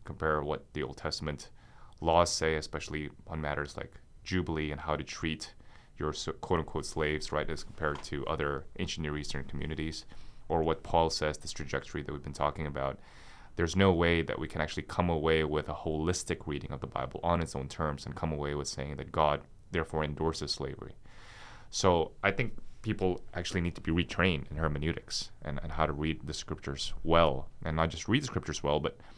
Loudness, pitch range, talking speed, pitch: -33 LUFS, 75-85 Hz, 200 wpm, 80 Hz